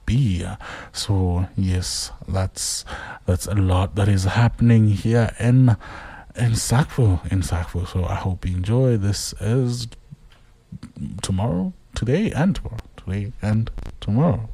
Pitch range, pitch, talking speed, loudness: 90-115 Hz, 100 Hz, 120 wpm, -21 LUFS